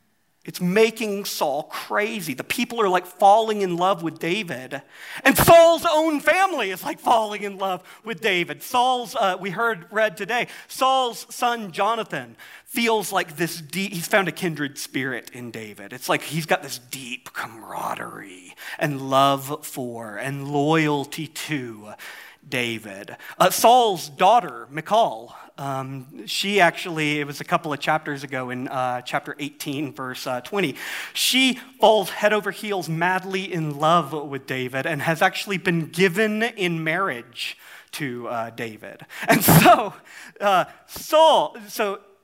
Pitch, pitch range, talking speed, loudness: 170 Hz, 140-210 Hz, 150 wpm, -22 LUFS